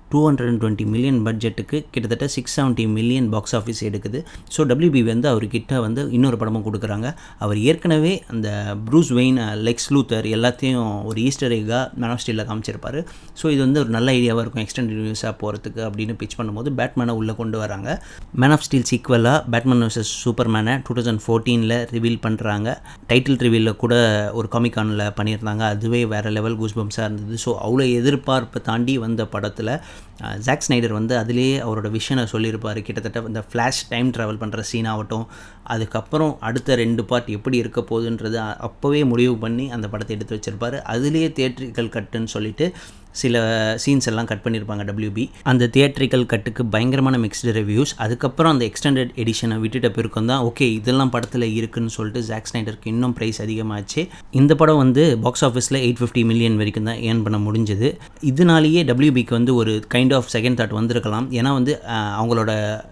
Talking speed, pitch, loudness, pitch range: 160 wpm, 115 Hz, -20 LUFS, 110-125 Hz